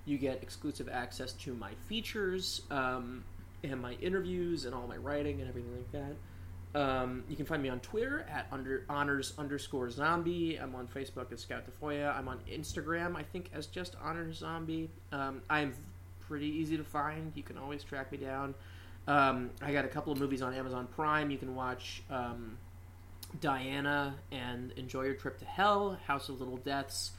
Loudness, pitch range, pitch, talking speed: -37 LUFS, 115-145 Hz, 130 Hz, 185 wpm